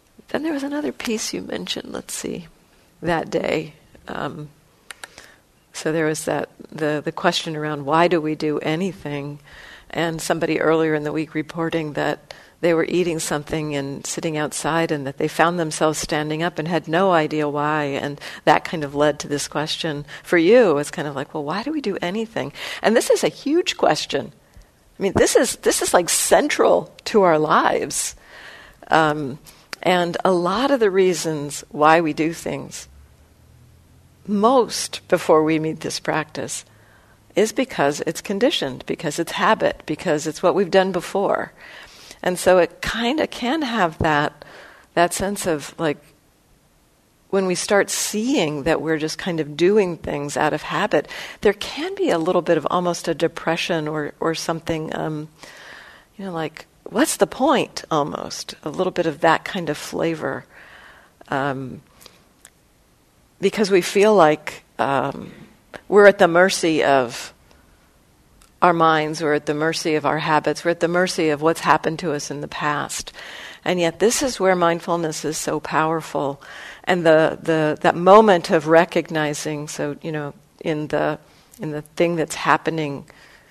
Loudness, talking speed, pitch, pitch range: -20 LUFS, 165 wpm, 160 Hz, 150-180 Hz